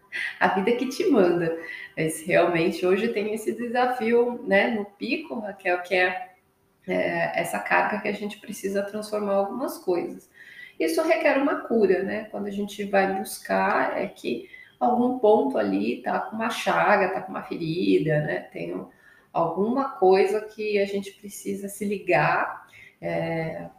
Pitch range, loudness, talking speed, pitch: 185-235 Hz, -25 LUFS, 155 wpm, 205 Hz